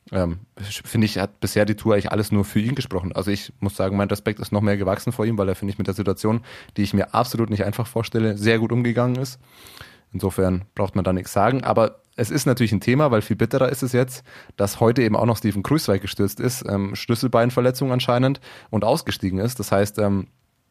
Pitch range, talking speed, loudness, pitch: 100-120 Hz, 230 wpm, -22 LUFS, 110 Hz